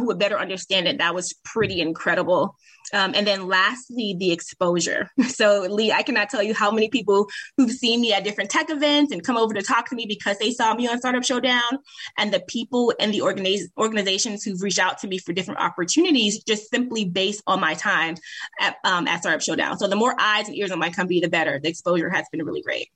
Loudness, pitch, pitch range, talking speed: -22 LUFS, 205 Hz, 190-235 Hz, 230 wpm